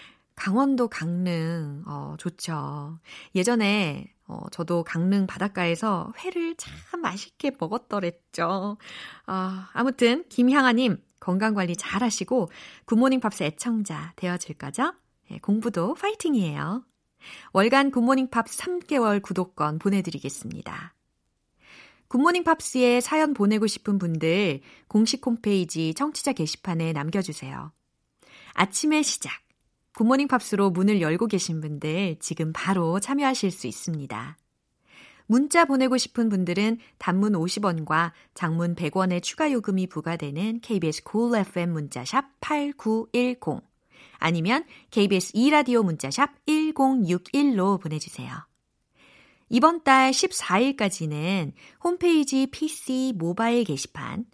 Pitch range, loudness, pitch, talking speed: 170-260 Hz, -25 LUFS, 205 Hz, 255 characters per minute